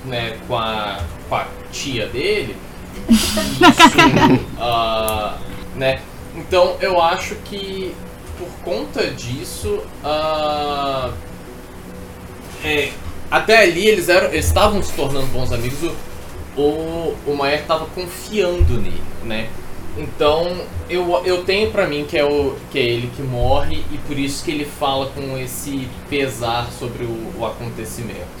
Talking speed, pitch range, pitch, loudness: 130 wpm, 115-170 Hz, 140 Hz, -18 LUFS